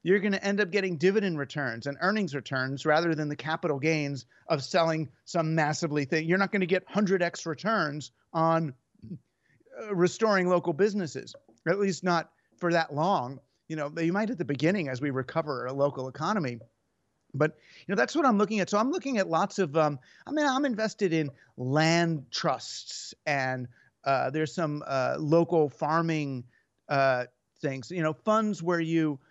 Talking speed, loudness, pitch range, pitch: 180 wpm, -28 LUFS, 140-190 Hz, 160 Hz